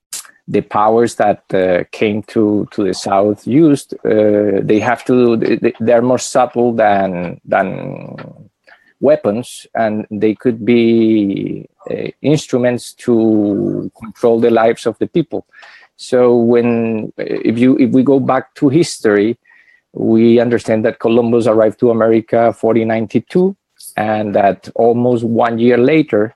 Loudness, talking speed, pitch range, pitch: -14 LUFS, 130 wpm, 110-125 Hz, 115 Hz